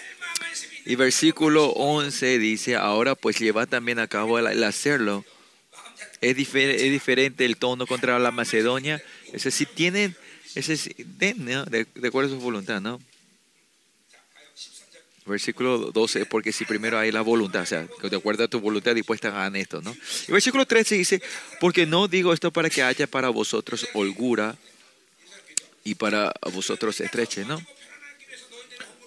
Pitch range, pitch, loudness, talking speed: 115-160 Hz, 125 Hz, -24 LUFS, 145 wpm